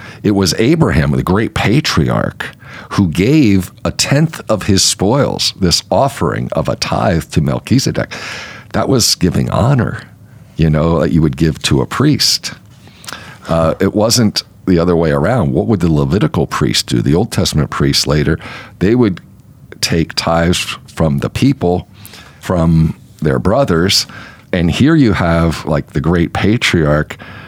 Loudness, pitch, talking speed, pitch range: -13 LUFS, 95 Hz, 150 wpm, 85-110 Hz